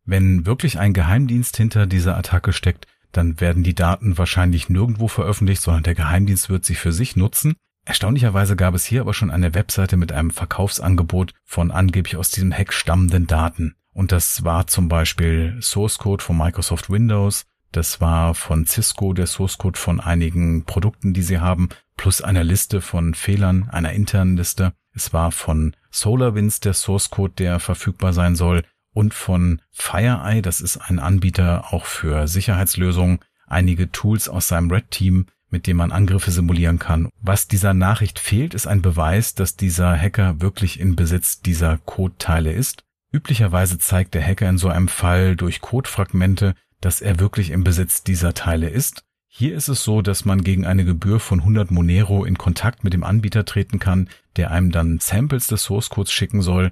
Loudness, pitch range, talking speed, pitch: -19 LUFS, 85-100 Hz, 180 wpm, 95 Hz